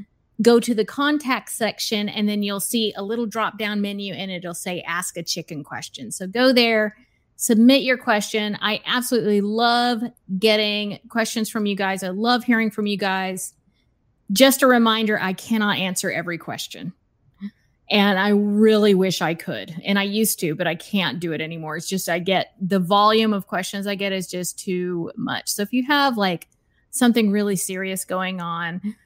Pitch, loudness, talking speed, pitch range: 205 Hz, -21 LUFS, 185 wpm, 185-225 Hz